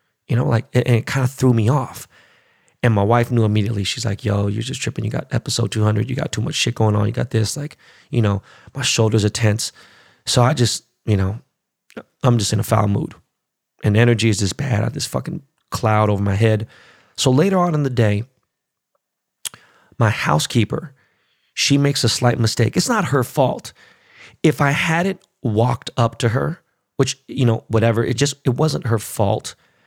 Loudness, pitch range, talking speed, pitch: -19 LUFS, 110-135 Hz, 205 wpm, 120 Hz